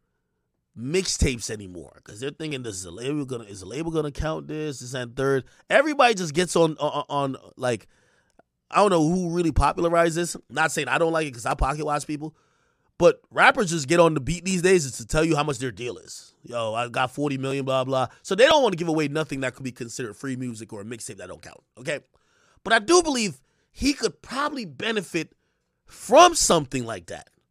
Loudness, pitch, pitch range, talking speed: -23 LUFS, 150 Hz, 125-170 Hz, 220 wpm